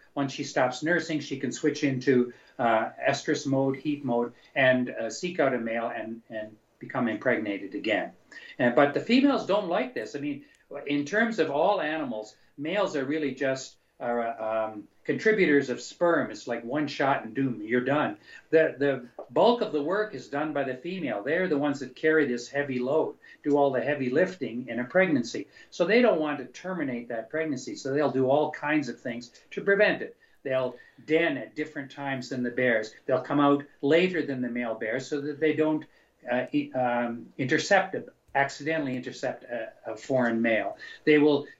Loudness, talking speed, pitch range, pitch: -27 LUFS, 190 wpm, 125-155 Hz, 140 Hz